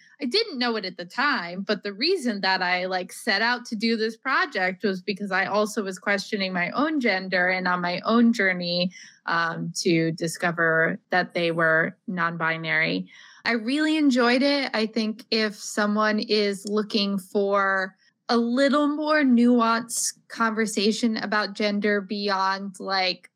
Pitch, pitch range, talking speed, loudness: 205 Hz, 185-230 Hz, 155 wpm, -24 LUFS